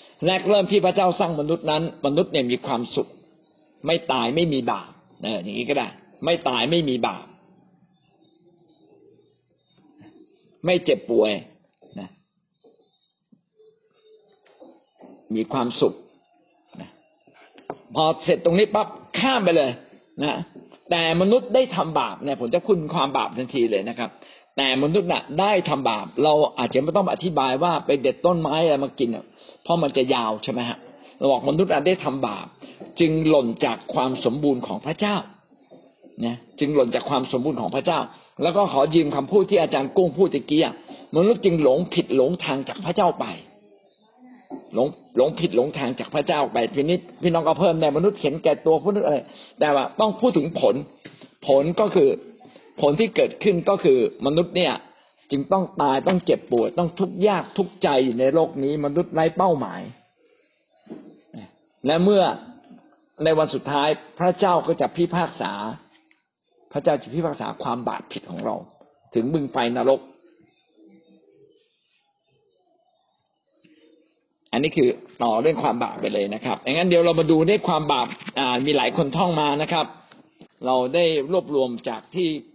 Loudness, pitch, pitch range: -22 LUFS, 165 Hz, 140-200 Hz